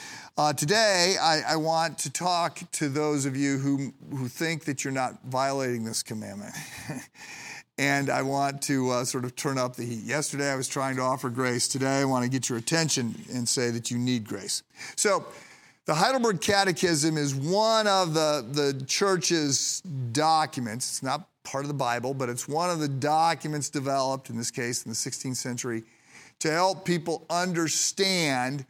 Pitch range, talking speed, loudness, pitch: 125-160 Hz, 180 wpm, -27 LUFS, 140 Hz